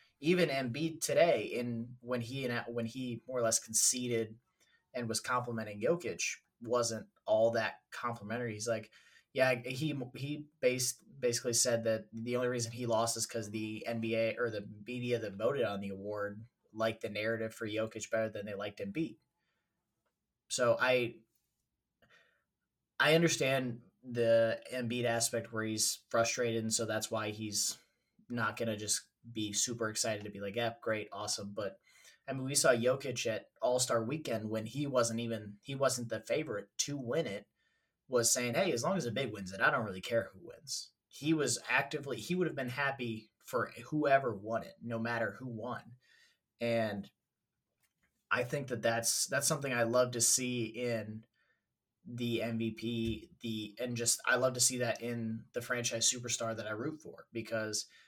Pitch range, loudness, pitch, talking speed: 110-125 Hz, -34 LUFS, 115 Hz, 175 wpm